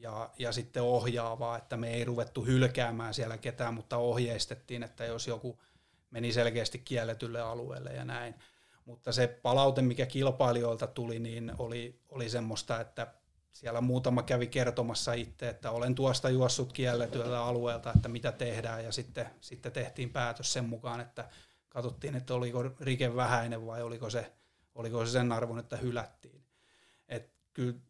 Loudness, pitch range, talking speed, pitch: -34 LUFS, 115-125 Hz, 155 wpm, 120 Hz